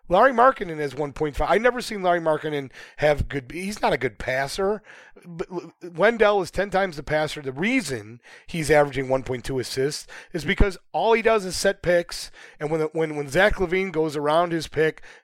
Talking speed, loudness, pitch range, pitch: 195 wpm, -23 LUFS, 150-195 Hz, 165 Hz